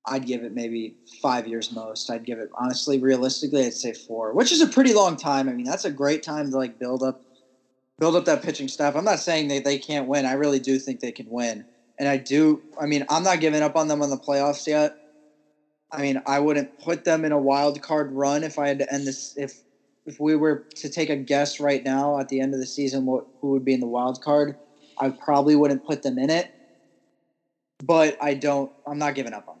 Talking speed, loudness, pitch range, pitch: 245 wpm, -23 LUFS, 130-150 Hz, 140 Hz